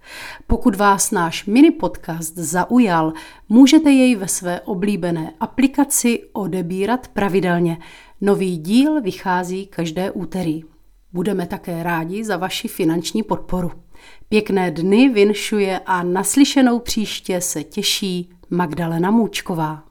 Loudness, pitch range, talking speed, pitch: -18 LUFS, 175-215 Hz, 110 wpm, 190 Hz